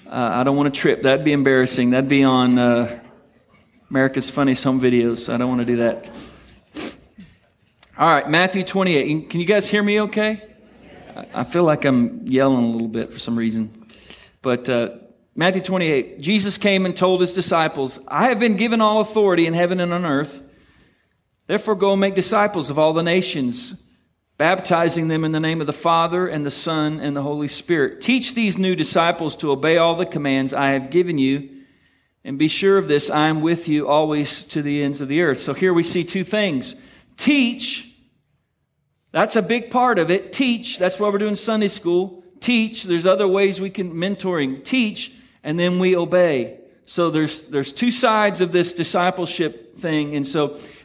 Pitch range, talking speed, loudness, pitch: 140-200 Hz, 190 wpm, -19 LUFS, 170 Hz